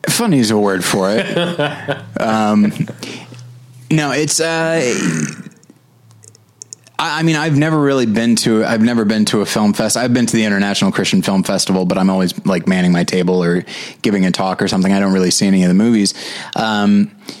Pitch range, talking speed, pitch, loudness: 95-145 Hz, 190 wpm, 115 Hz, -15 LUFS